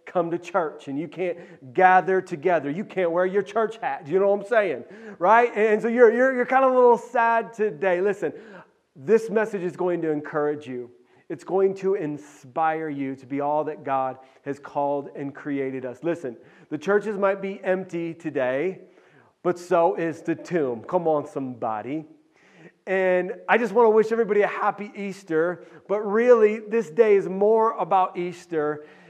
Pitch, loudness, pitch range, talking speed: 180 Hz, -23 LUFS, 155-210 Hz, 180 wpm